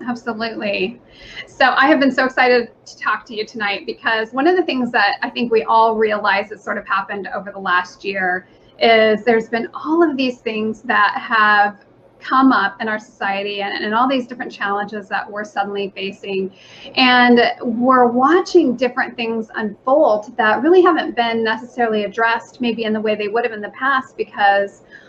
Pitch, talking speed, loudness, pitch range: 225 Hz, 185 wpm, -17 LUFS, 205-250 Hz